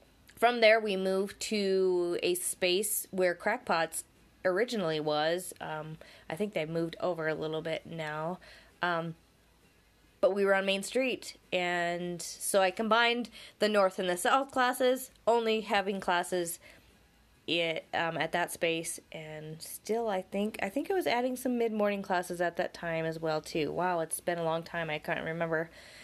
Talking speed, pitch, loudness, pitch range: 170 wpm, 180 Hz, -31 LUFS, 165-215 Hz